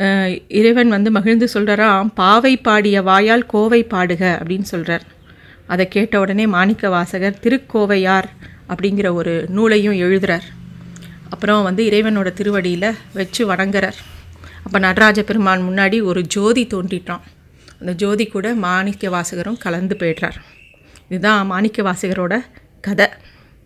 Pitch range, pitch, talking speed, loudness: 180-215 Hz, 195 Hz, 115 wpm, -16 LUFS